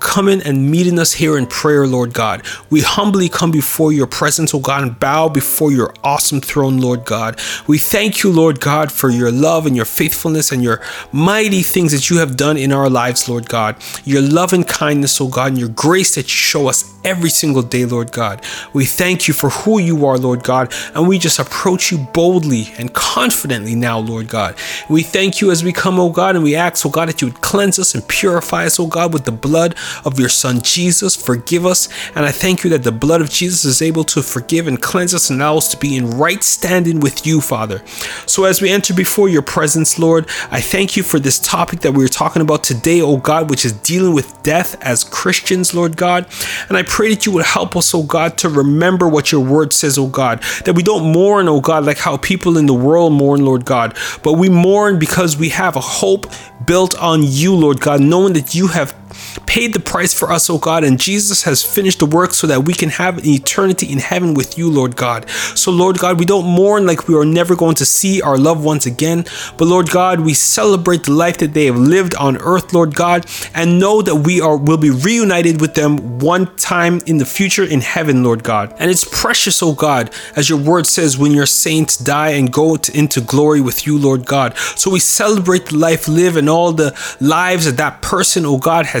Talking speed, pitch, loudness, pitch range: 235 wpm, 160 Hz, -13 LUFS, 135-180 Hz